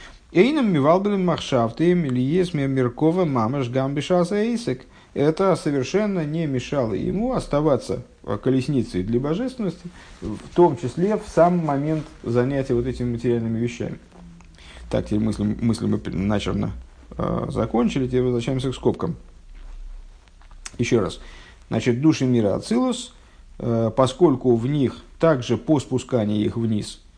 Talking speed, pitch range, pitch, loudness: 115 wpm, 115-165 Hz, 130 Hz, -22 LUFS